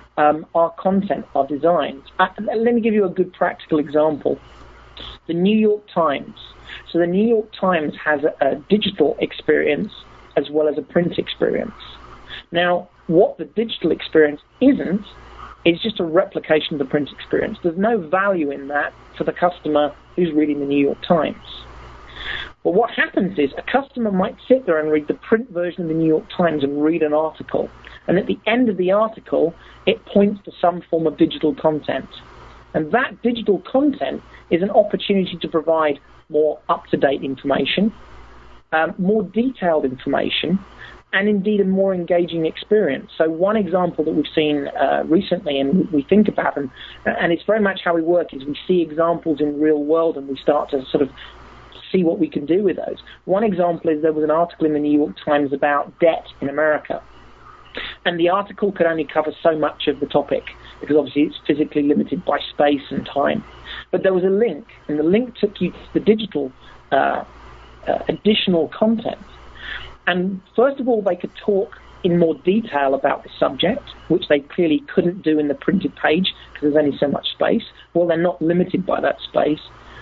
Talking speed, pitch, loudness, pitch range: 185 wpm, 165 Hz, -19 LUFS, 150-195 Hz